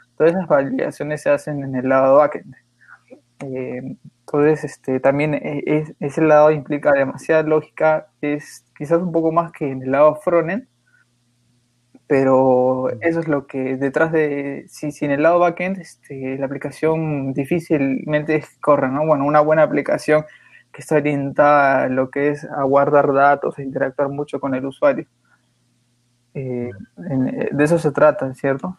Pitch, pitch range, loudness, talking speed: 145 Hz, 135-155 Hz, -18 LUFS, 150 wpm